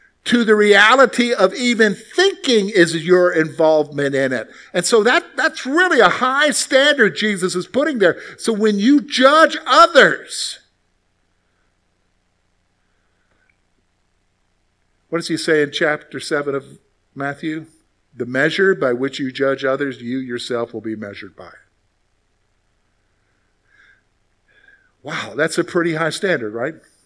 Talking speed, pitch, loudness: 125 wpm, 150 Hz, -16 LUFS